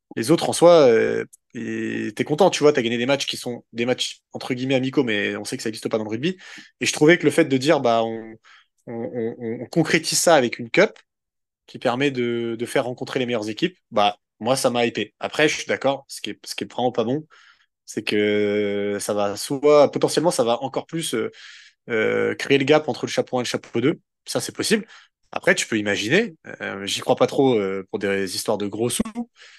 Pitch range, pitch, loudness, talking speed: 110-150 Hz, 125 Hz, -21 LUFS, 240 wpm